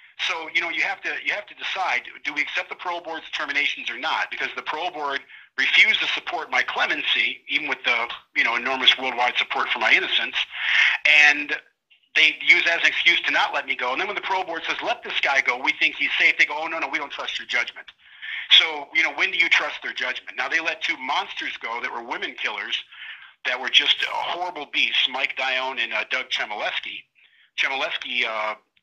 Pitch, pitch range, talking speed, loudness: 130 Hz, 125-150 Hz, 225 wpm, -21 LUFS